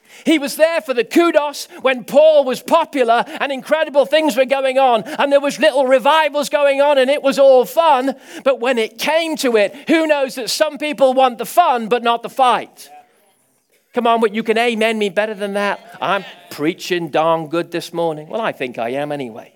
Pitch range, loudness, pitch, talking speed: 220-290 Hz, -16 LUFS, 265 Hz, 210 wpm